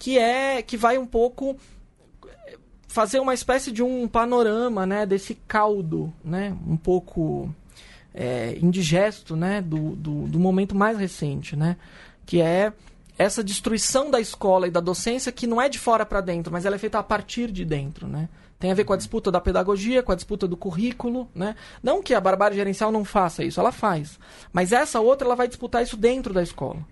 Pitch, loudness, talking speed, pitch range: 205 Hz, -23 LUFS, 195 wpm, 180-235 Hz